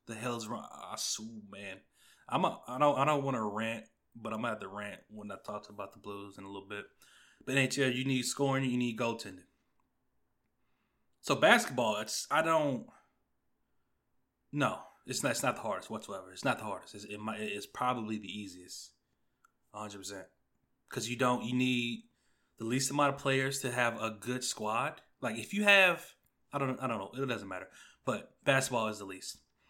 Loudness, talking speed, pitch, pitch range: -33 LUFS, 195 wpm, 115 Hz, 105-130 Hz